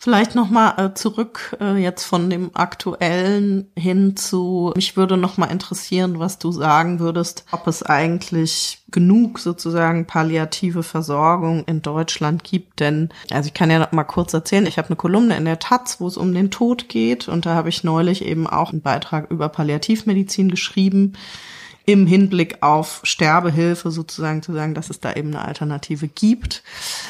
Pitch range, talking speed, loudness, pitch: 160-195 Hz, 170 wpm, -19 LUFS, 175 Hz